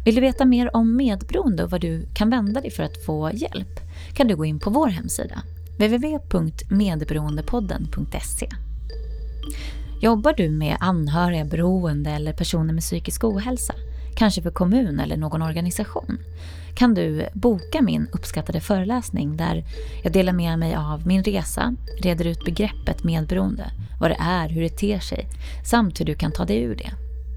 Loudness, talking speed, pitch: -23 LUFS, 160 wpm, 165 Hz